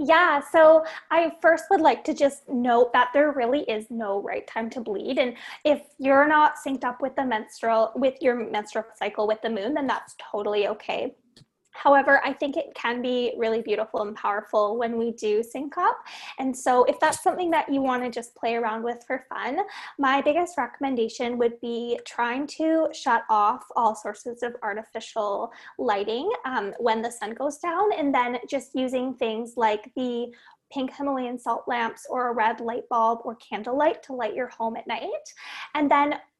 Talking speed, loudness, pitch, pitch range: 190 wpm, -25 LUFS, 250 Hz, 230-285 Hz